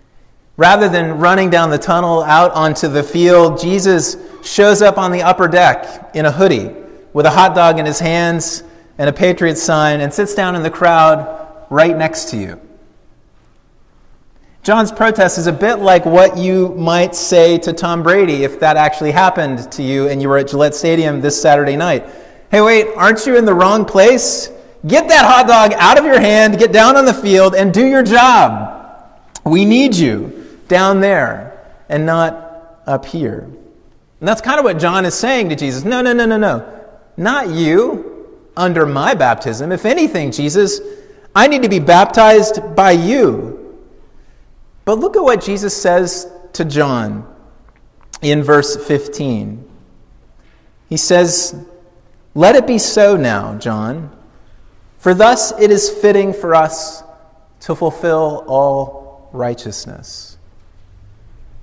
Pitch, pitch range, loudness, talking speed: 175 Hz, 150-205 Hz, -11 LUFS, 160 wpm